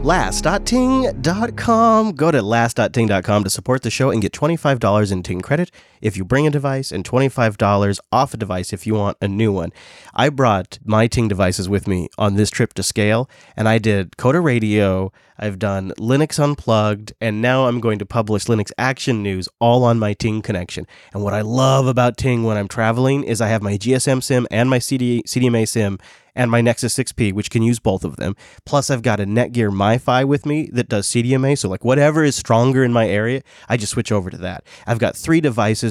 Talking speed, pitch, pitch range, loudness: 205 wpm, 115 Hz, 105-130 Hz, -18 LUFS